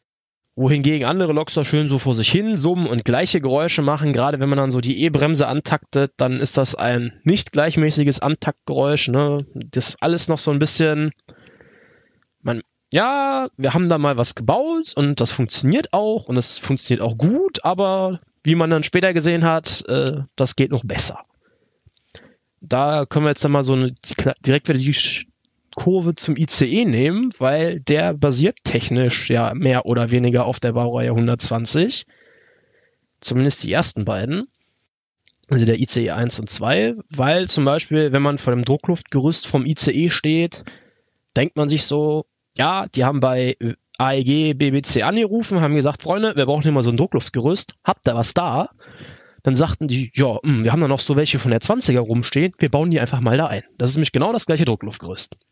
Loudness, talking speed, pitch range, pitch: -19 LUFS, 180 wpm, 125-160 Hz, 145 Hz